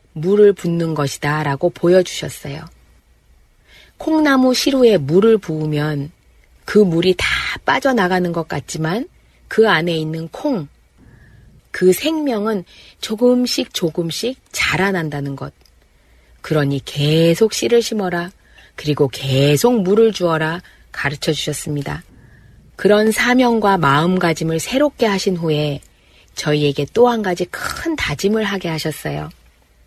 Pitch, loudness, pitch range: 170 Hz, -17 LUFS, 150-220 Hz